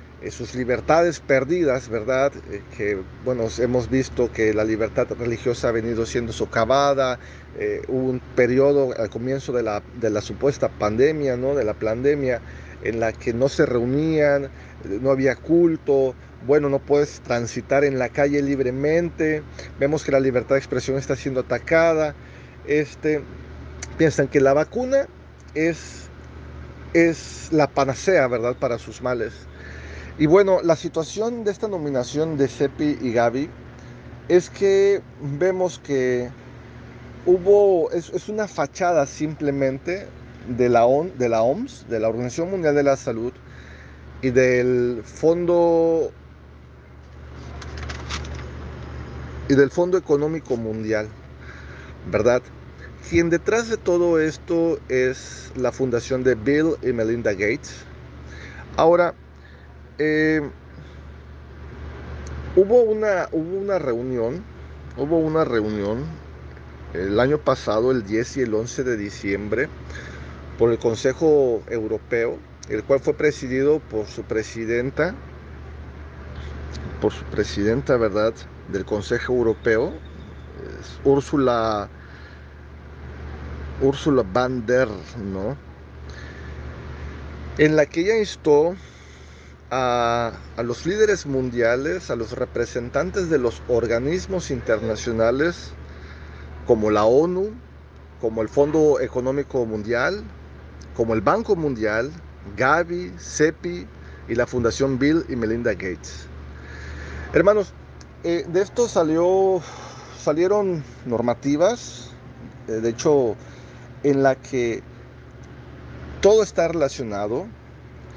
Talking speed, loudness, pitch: 115 wpm, -21 LUFS, 120 Hz